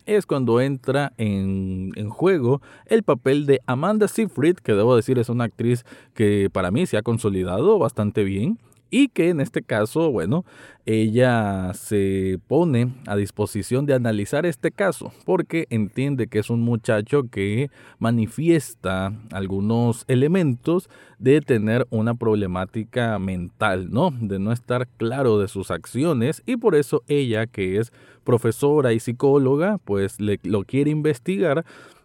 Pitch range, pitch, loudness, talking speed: 105-145 Hz, 120 Hz, -22 LUFS, 145 wpm